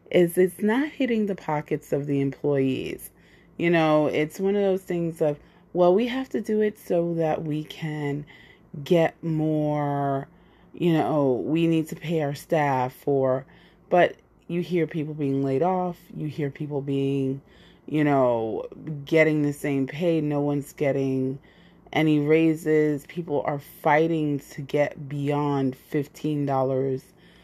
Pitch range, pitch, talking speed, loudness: 140-170 Hz, 150 Hz, 145 wpm, -25 LUFS